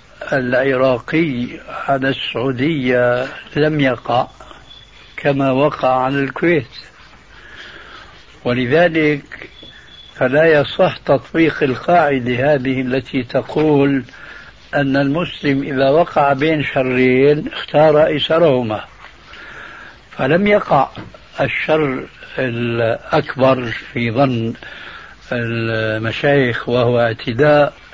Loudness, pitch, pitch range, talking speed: -16 LUFS, 135 Hz, 125-150 Hz, 75 wpm